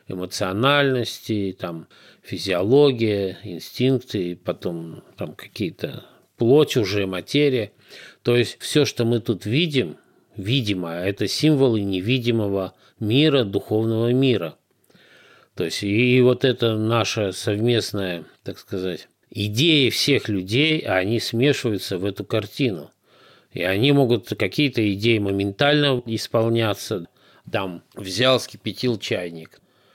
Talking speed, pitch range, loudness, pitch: 105 wpm, 100-130 Hz, -21 LUFS, 110 Hz